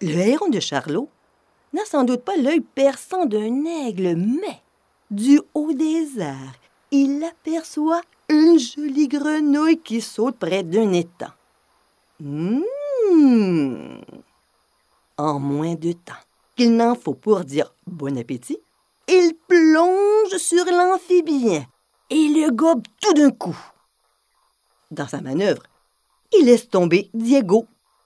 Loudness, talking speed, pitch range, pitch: -19 LUFS, 120 wpm, 195-320 Hz, 275 Hz